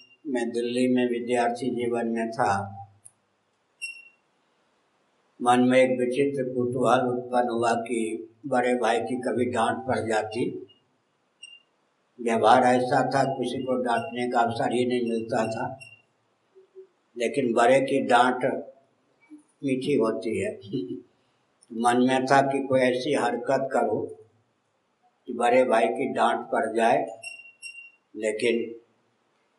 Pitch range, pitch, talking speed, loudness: 115-130 Hz, 125 Hz, 115 wpm, -25 LUFS